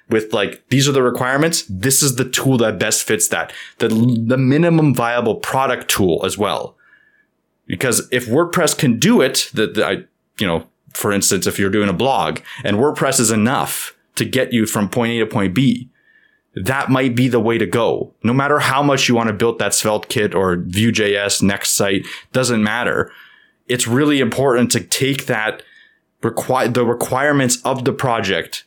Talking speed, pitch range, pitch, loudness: 185 wpm, 115-135 Hz, 125 Hz, -16 LUFS